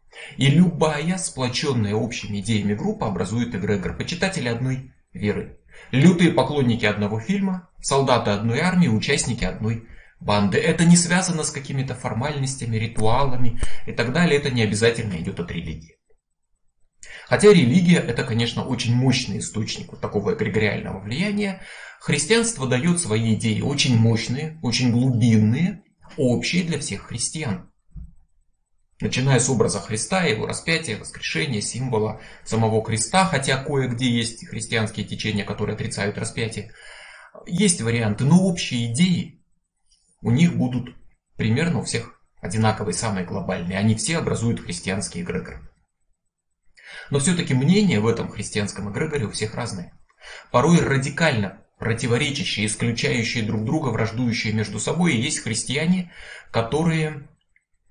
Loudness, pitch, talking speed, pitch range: -22 LUFS, 120 Hz, 125 wpm, 110-155 Hz